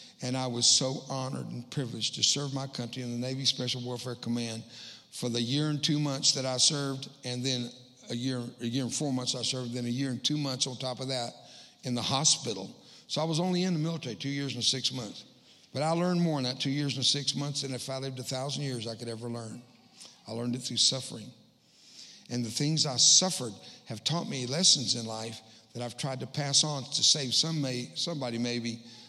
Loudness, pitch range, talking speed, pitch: -29 LUFS, 120-145 Hz, 230 wpm, 130 Hz